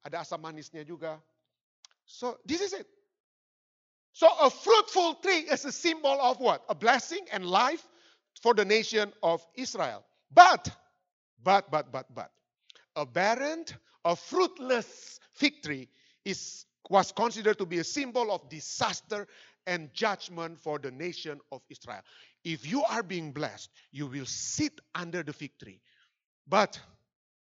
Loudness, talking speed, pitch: -28 LUFS, 145 wpm, 185 Hz